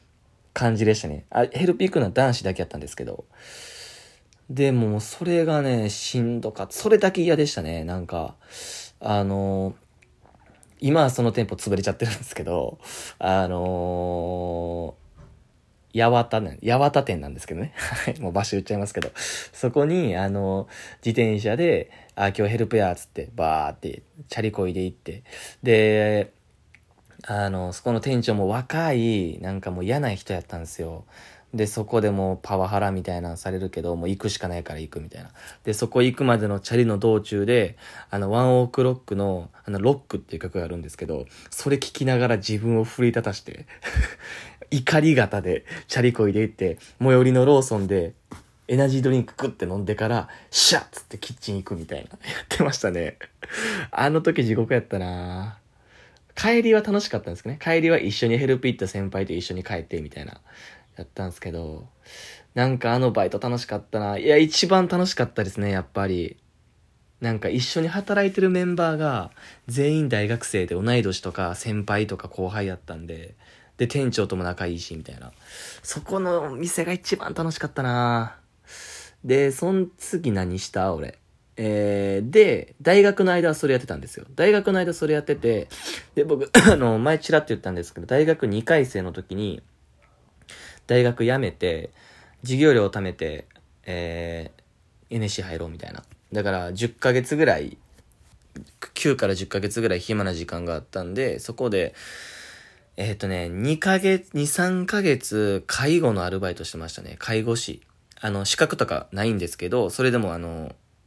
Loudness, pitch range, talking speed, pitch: -23 LUFS, 95-130 Hz, 340 characters per minute, 110 Hz